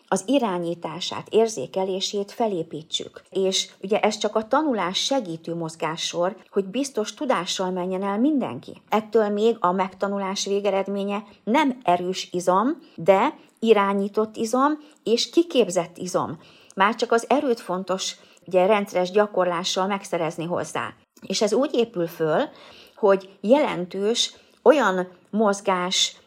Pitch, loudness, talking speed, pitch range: 200 Hz, -23 LUFS, 115 wpm, 180-230 Hz